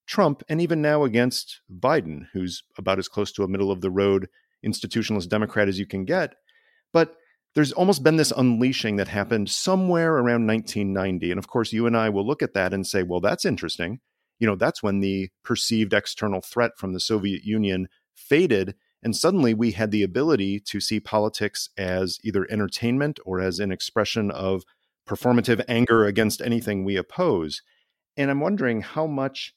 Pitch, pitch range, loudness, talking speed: 105 Hz, 95-120 Hz, -24 LUFS, 180 wpm